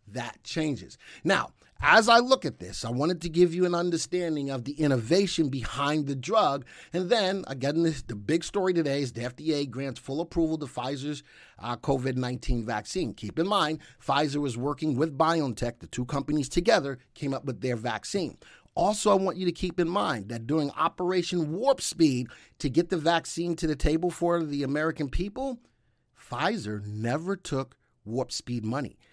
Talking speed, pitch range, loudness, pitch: 180 wpm, 130-170 Hz, -28 LUFS, 150 Hz